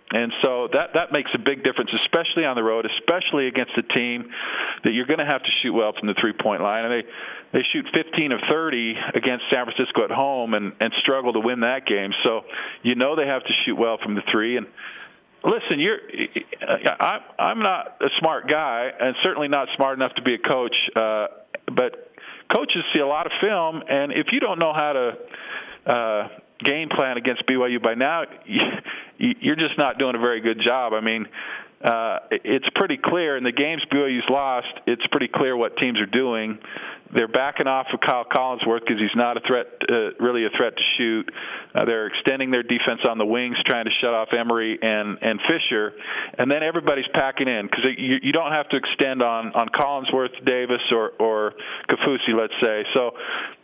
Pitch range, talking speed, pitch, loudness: 115-150 Hz, 200 wpm, 130 Hz, -22 LUFS